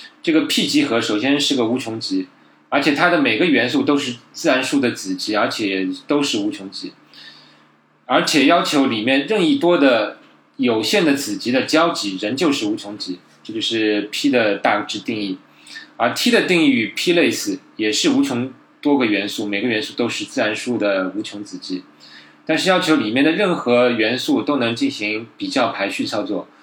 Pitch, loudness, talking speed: 145 Hz, -18 LUFS, 270 characters per minute